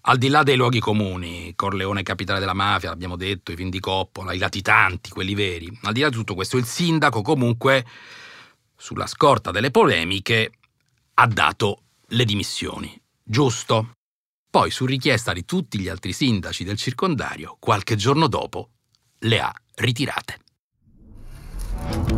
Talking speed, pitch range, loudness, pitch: 140 wpm, 95-125 Hz, -21 LUFS, 105 Hz